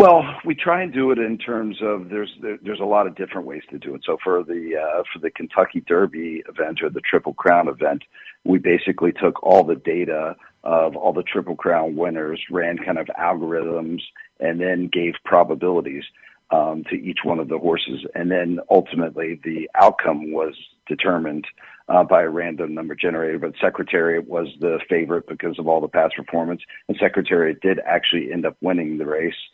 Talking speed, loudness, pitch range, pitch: 190 wpm, -21 LUFS, 80-105 Hz, 85 Hz